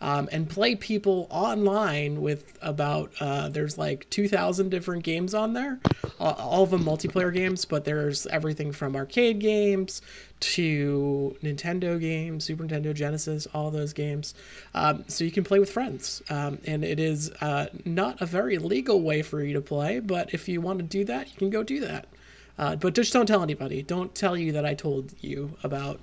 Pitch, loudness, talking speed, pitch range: 160 Hz, -27 LUFS, 190 wpm, 150-190 Hz